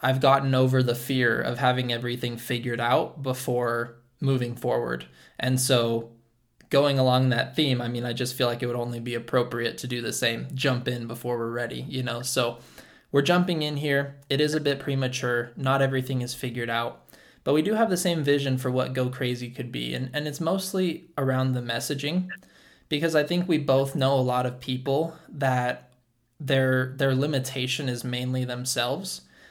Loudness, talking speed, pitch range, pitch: -26 LUFS, 190 wpm, 120-140 Hz, 130 Hz